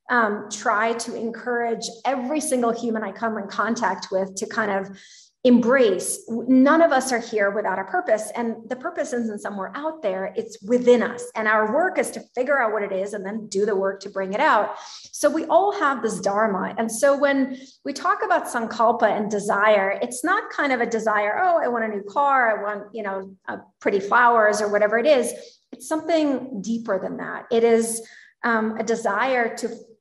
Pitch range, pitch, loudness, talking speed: 210-260 Hz, 230 Hz, -22 LUFS, 205 wpm